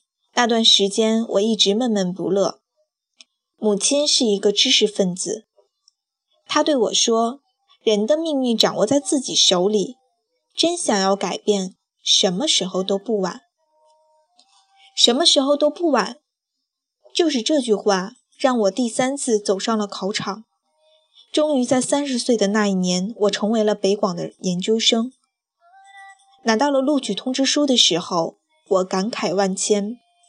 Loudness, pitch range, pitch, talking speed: -19 LUFS, 200-295 Hz, 230 Hz, 210 characters per minute